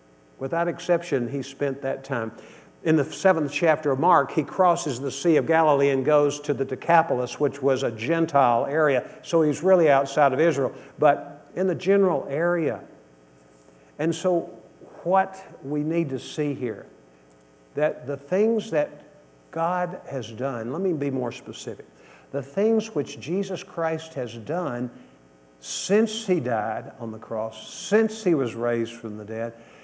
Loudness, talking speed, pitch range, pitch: -24 LUFS, 160 wpm, 115-170 Hz, 140 Hz